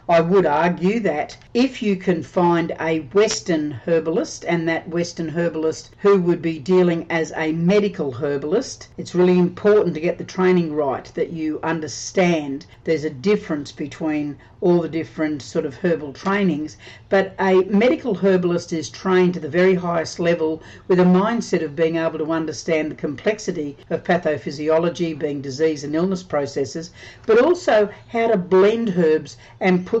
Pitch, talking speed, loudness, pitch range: 165 Hz, 160 wpm, -20 LUFS, 155-185 Hz